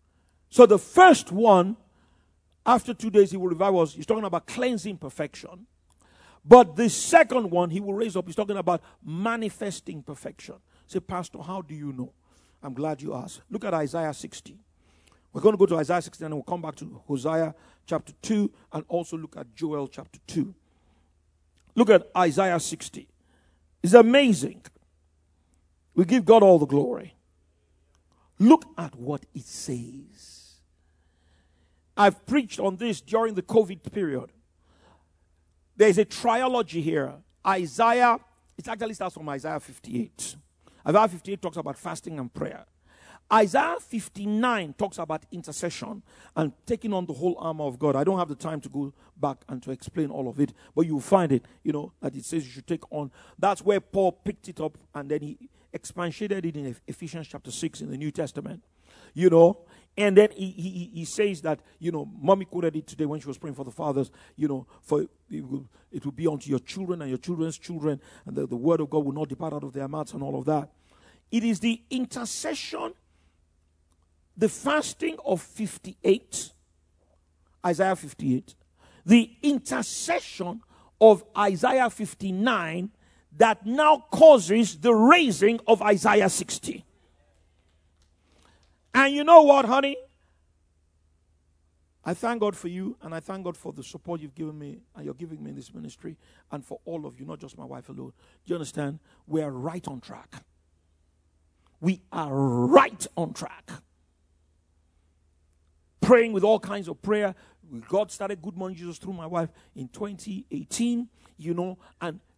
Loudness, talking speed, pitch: -24 LUFS, 165 wpm, 160 Hz